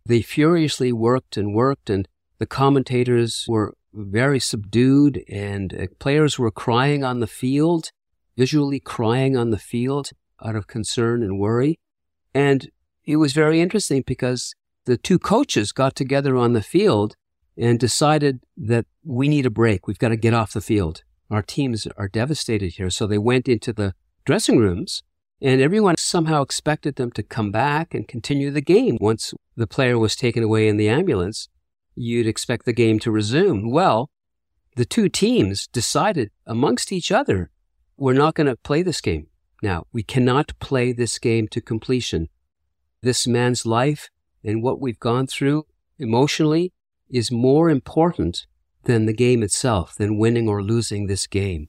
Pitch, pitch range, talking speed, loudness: 120 Hz, 105-135 Hz, 165 wpm, -20 LUFS